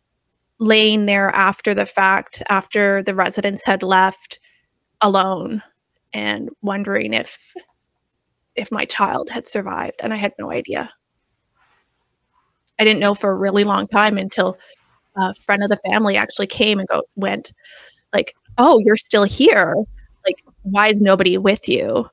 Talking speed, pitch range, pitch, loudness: 145 wpm, 195-215 Hz, 200 Hz, -17 LUFS